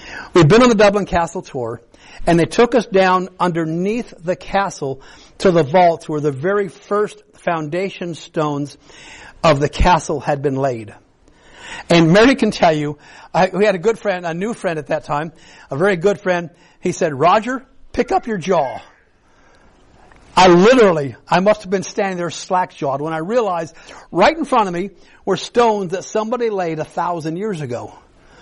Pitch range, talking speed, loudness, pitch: 155-205 Hz, 180 wpm, -17 LUFS, 180 Hz